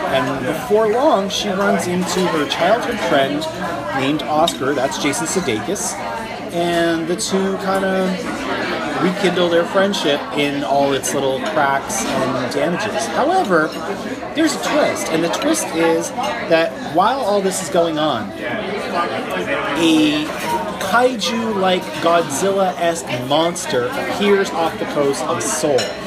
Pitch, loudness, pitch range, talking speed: 185 Hz, -18 LUFS, 165-200 Hz, 130 wpm